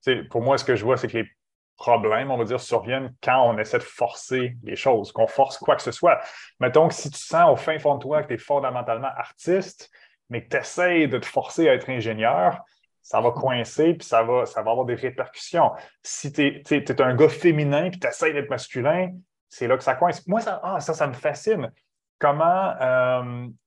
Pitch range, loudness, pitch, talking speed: 125-155 Hz, -23 LUFS, 135 Hz, 230 wpm